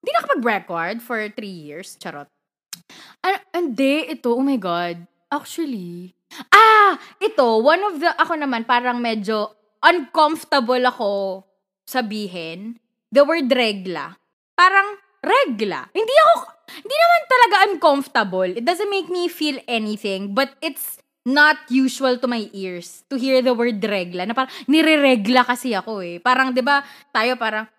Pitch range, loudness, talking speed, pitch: 215-320 Hz, -18 LUFS, 145 wpm, 255 Hz